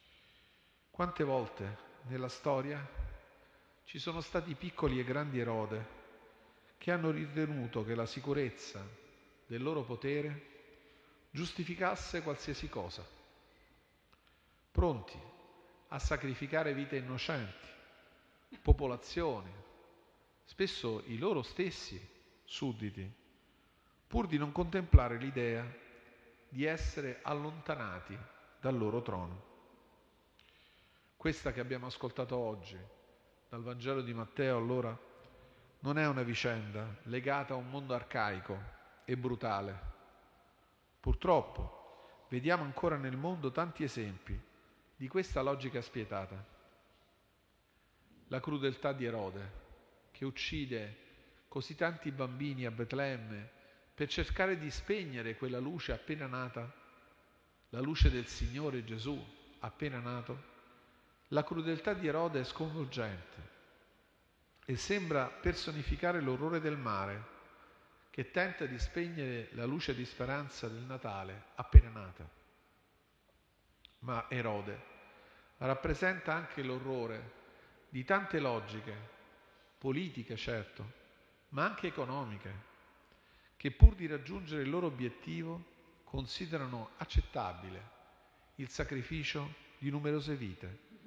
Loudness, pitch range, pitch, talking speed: -38 LUFS, 110-150 Hz, 130 Hz, 100 wpm